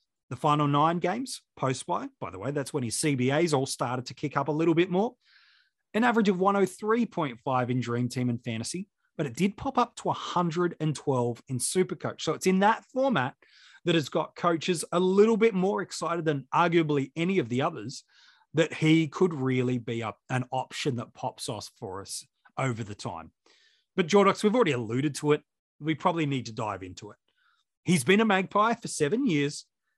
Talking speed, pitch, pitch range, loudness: 195 wpm, 155 Hz, 130-185 Hz, -27 LUFS